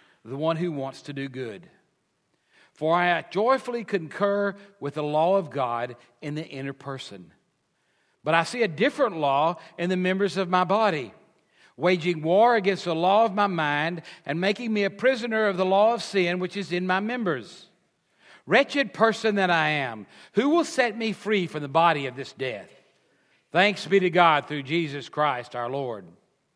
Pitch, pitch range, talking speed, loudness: 180 Hz, 150-200 Hz, 180 wpm, -24 LUFS